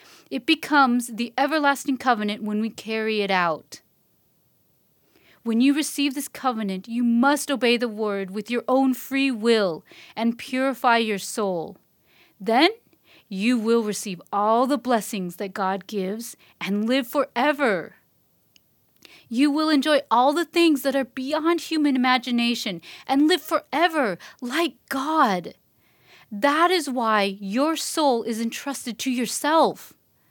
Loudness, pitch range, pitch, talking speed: -23 LUFS, 220-285 Hz, 250 Hz, 135 wpm